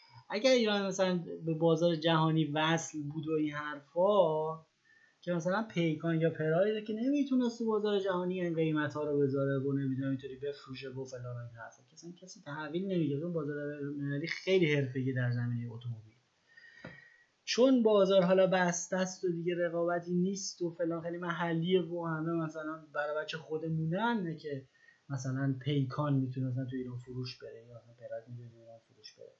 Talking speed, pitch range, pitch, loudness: 155 wpm, 140-185 Hz, 160 Hz, -33 LUFS